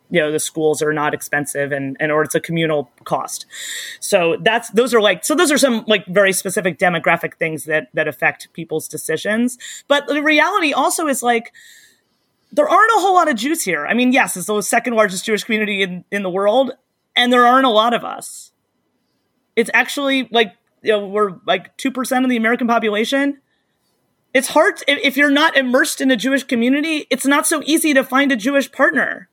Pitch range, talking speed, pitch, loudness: 190-280 Hz, 205 wpm, 240 Hz, -16 LUFS